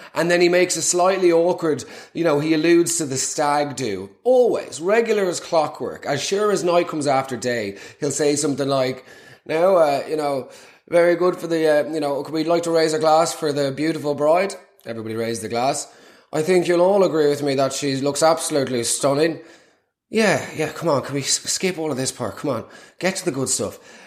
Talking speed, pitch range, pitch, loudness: 215 wpm, 140-170 Hz, 155 Hz, -20 LUFS